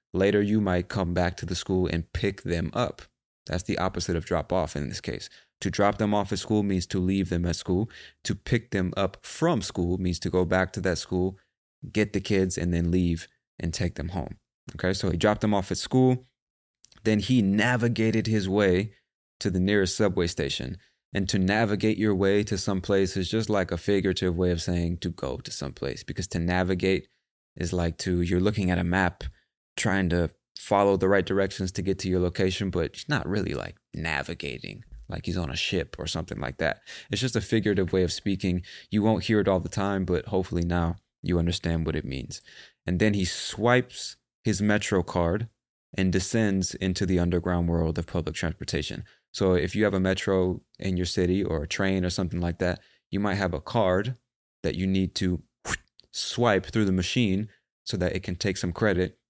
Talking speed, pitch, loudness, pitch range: 210 wpm, 95 Hz, -27 LUFS, 90-100 Hz